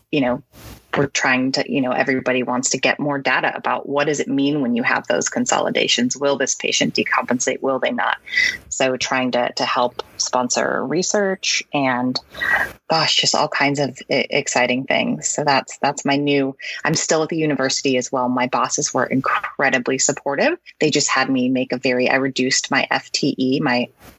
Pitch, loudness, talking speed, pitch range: 135 Hz, -19 LUFS, 185 wpm, 125-145 Hz